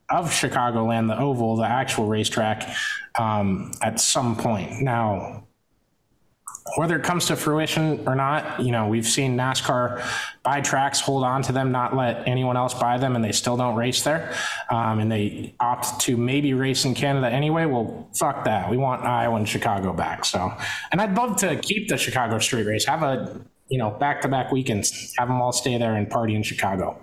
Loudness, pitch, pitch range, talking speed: -23 LUFS, 125 Hz, 115-135 Hz, 200 wpm